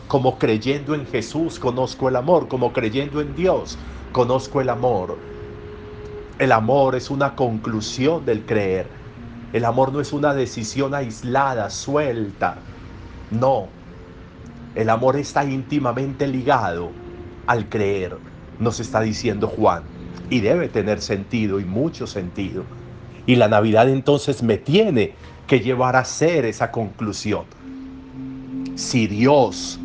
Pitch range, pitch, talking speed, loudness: 100-130 Hz, 115 Hz, 125 wpm, -20 LUFS